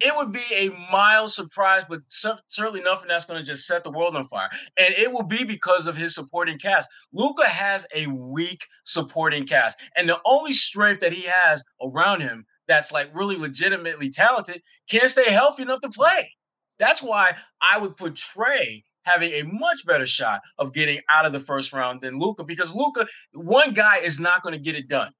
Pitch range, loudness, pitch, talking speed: 160-215 Hz, -21 LUFS, 180 Hz, 200 wpm